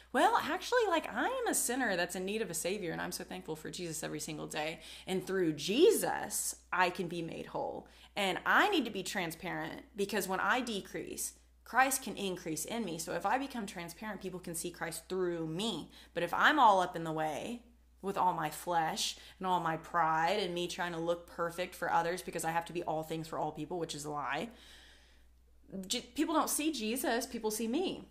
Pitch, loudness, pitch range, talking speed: 180 Hz, -34 LUFS, 165-225 Hz, 215 wpm